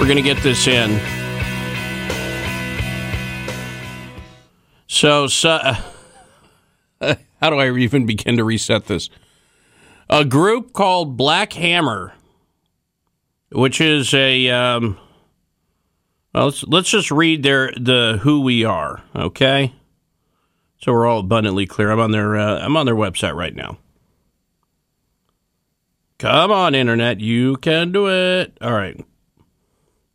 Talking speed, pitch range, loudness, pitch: 120 wpm, 85-140 Hz, -17 LUFS, 115 Hz